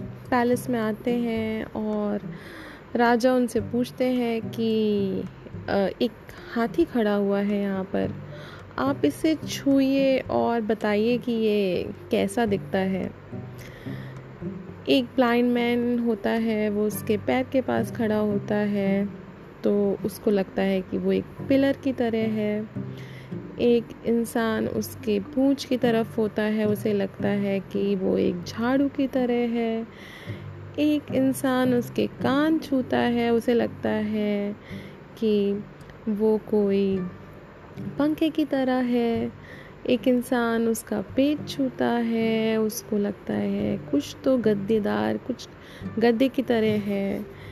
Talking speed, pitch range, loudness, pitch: 130 wpm, 200-245 Hz, -25 LUFS, 225 Hz